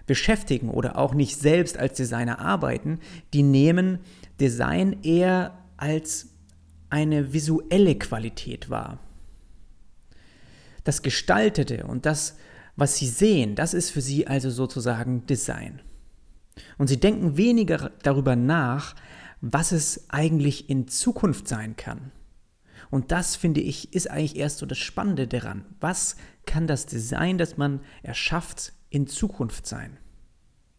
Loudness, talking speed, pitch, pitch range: -24 LUFS, 125 wpm, 140 Hz, 120-165 Hz